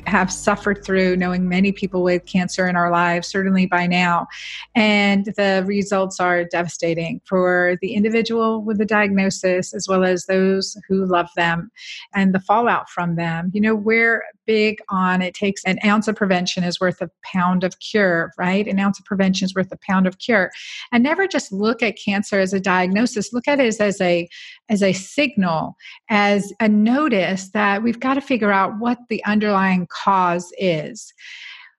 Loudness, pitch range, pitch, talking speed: -19 LUFS, 180-210 Hz, 195 Hz, 185 wpm